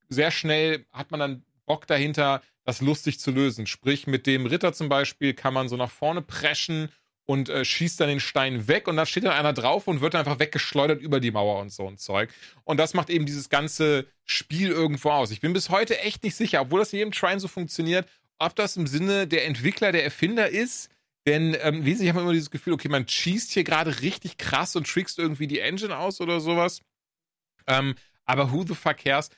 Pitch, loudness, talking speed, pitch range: 155 Hz, -25 LUFS, 225 wpm, 140-175 Hz